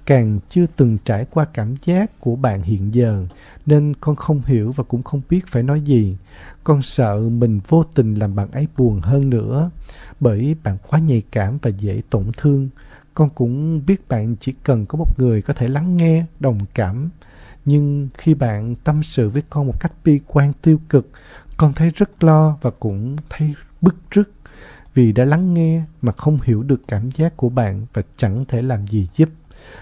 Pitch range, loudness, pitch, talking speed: 115-155 Hz, -18 LUFS, 135 Hz, 195 wpm